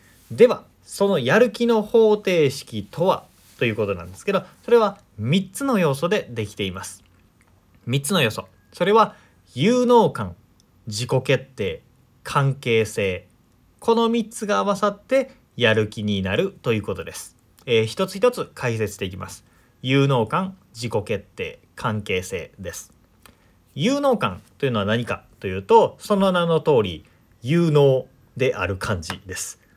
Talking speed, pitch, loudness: 270 characters per minute, 125 Hz, -21 LUFS